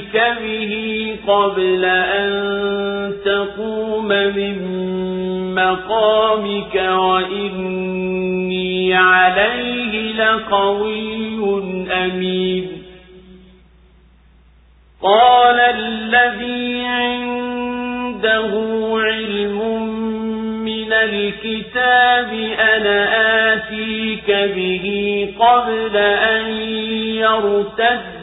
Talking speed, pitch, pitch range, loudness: 45 wpm, 215 Hz, 185-220 Hz, -16 LUFS